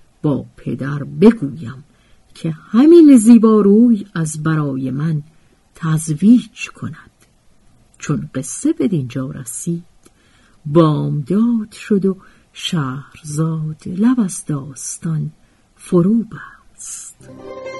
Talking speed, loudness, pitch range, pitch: 80 wpm, -15 LUFS, 150-220 Hz, 165 Hz